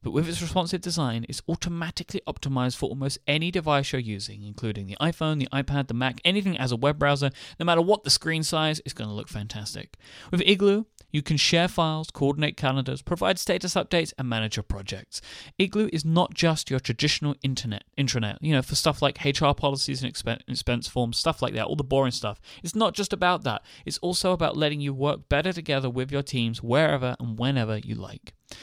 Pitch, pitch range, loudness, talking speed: 140 Hz, 125-165 Hz, -26 LUFS, 205 wpm